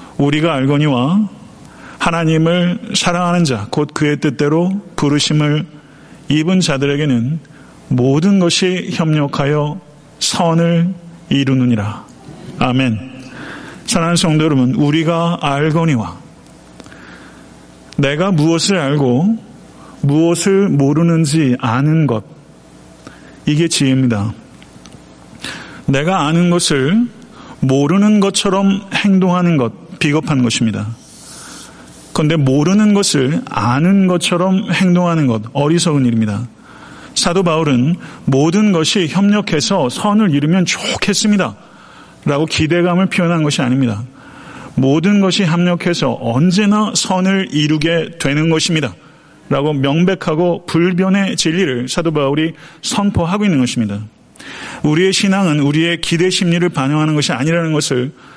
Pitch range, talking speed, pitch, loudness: 135-180 Hz, 260 characters per minute, 160 Hz, -14 LUFS